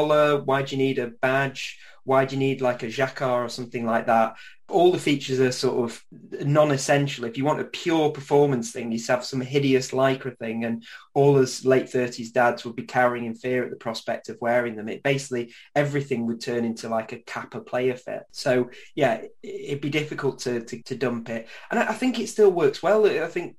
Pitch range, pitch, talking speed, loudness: 120-145 Hz, 130 Hz, 215 wpm, -24 LUFS